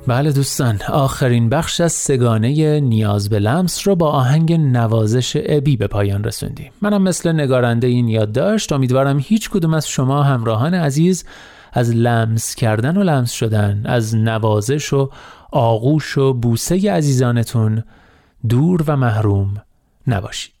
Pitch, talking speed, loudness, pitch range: 130 Hz, 140 wpm, -16 LUFS, 115-150 Hz